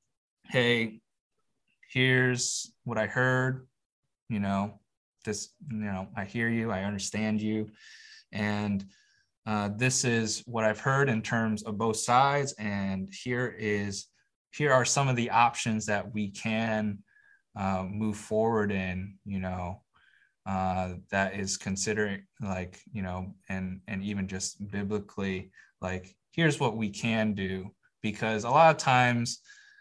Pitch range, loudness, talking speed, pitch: 100-120 Hz, -29 LUFS, 140 wpm, 110 Hz